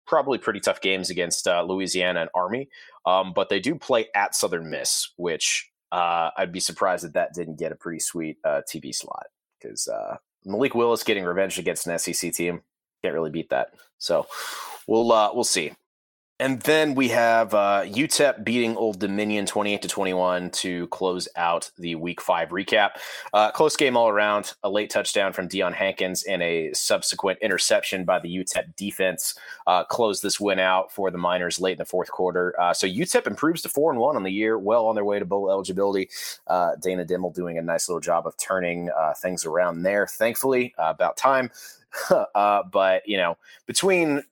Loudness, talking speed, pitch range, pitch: -24 LUFS, 195 wpm, 90-105 Hz, 95 Hz